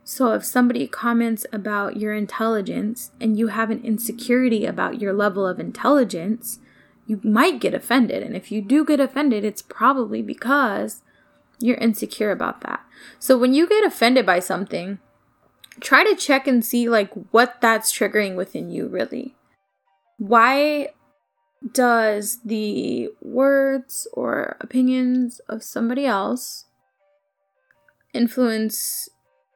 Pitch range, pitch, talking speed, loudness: 215-260 Hz, 235 Hz, 130 wpm, -20 LUFS